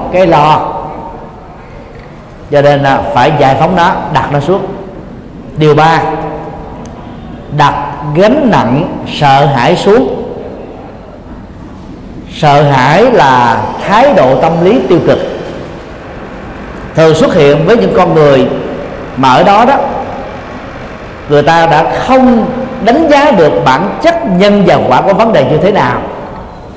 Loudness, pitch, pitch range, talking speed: -8 LUFS, 155 Hz, 145-195 Hz, 130 wpm